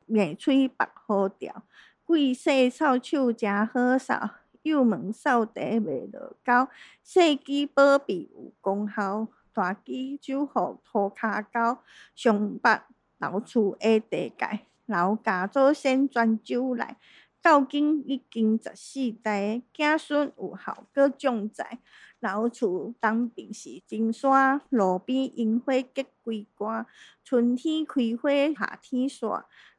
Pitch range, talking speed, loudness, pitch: 220-275 Hz, 165 characters per minute, -26 LUFS, 245 Hz